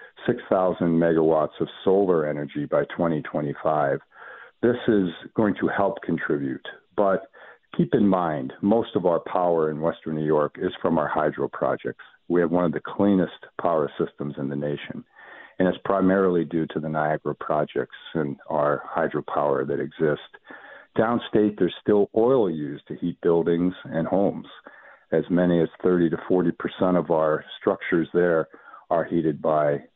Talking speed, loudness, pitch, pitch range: 155 wpm, -24 LUFS, 85 Hz, 75-90 Hz